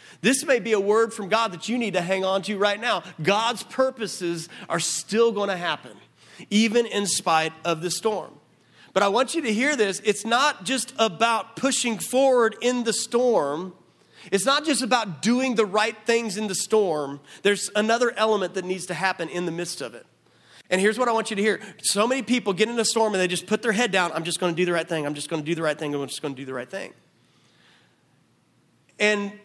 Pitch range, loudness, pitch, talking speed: 180-230 Hz, -23 LUFS, 210 Hz, 235 wpm